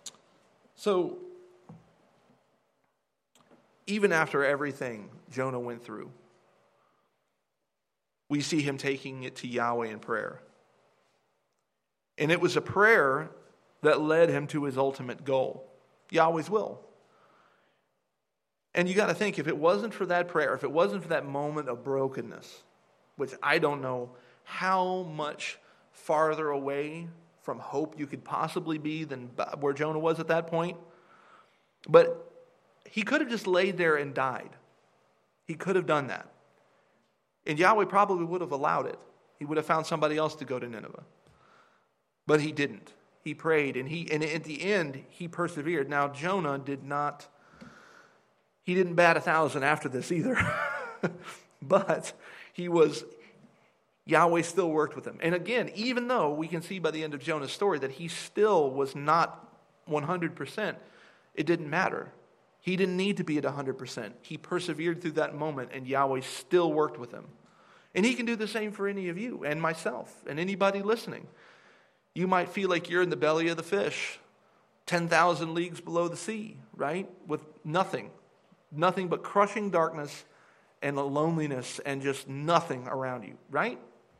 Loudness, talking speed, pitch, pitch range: -29 LUFS, 155 wpm, 160 Hz, 145-180 Hz